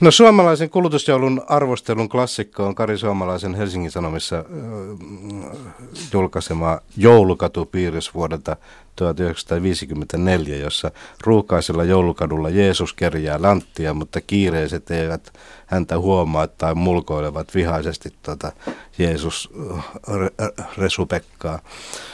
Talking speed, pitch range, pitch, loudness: 85 wpm, 80-100 Hz, 90 Hz, -19 LUFS